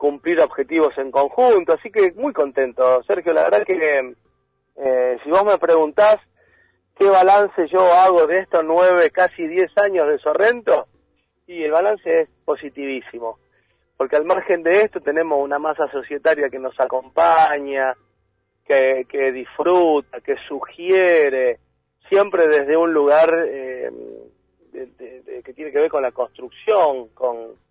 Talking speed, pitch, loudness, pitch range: 145 wpm, 160 Hz, -17 LUFS, 135-195 Hz